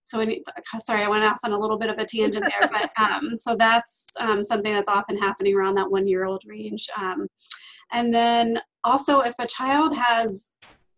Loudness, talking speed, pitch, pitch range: -23 LUFS, 185 wpm, 220 Hz, 205-235 Hz